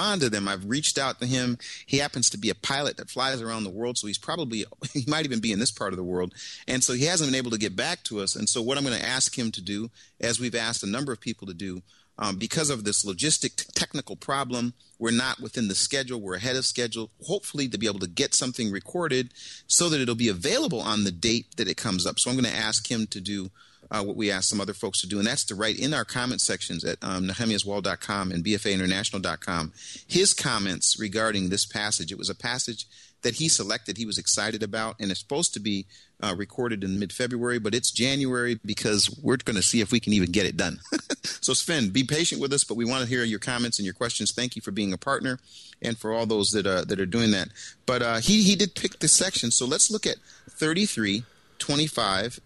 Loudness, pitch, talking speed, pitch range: -25 LUFS, 115 Hz, 245 wpm, 100-125 Hz